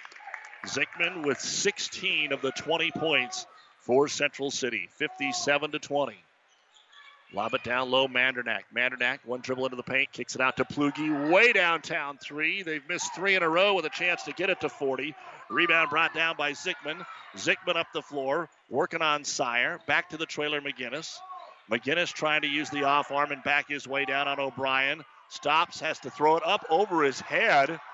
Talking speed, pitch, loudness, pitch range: 185 wpm, 145 Hz, -27 LUFS, 135-160 Hz